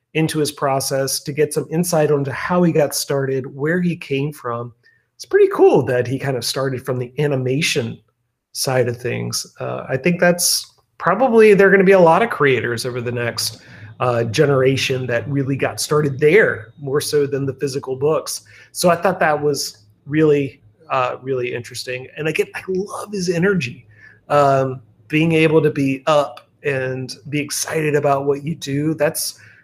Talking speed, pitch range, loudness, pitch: 180 wpm, 125-155 Hz, -18 LUFS, 140 Hz